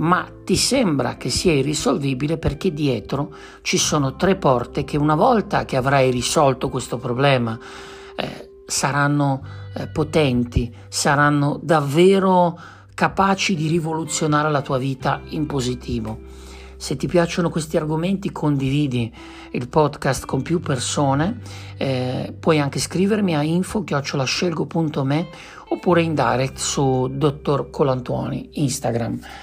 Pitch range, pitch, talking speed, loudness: 130-165 Hz, 145 Hz, 120 wpm, -20 LUFS